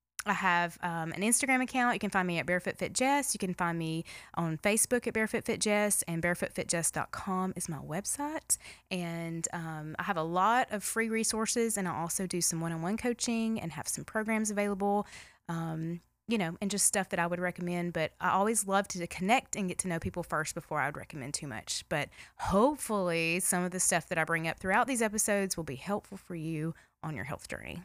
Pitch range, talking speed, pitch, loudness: 165-215 Hz, 220 wpm, 185 Hz, -31 LUFS